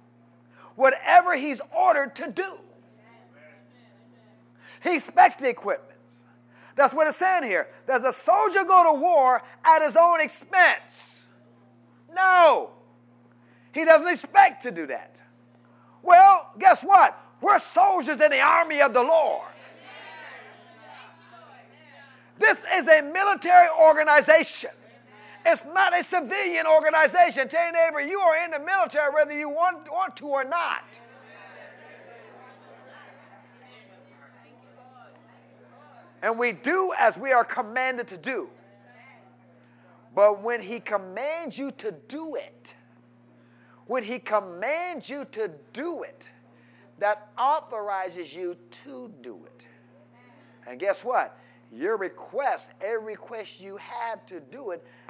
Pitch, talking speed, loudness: 280 Hz, 120 wpm, -22 LUFS